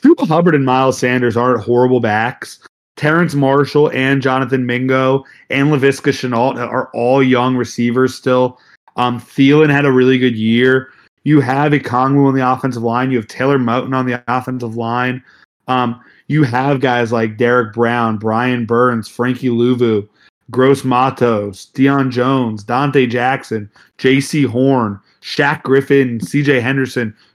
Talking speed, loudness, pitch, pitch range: 145 wpm, -14 LUFS, 130 Hz, 120-135 Hz